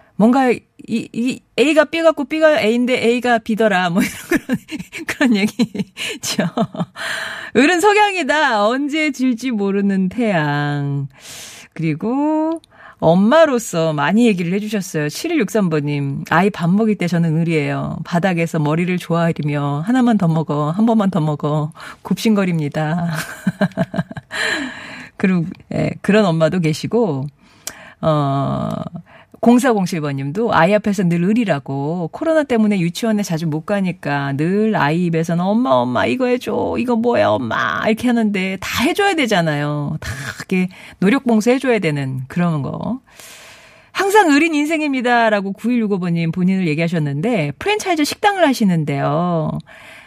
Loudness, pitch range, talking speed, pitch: -17 LUFS, 160-240 Hz, 280 characters per minute, 200 Hz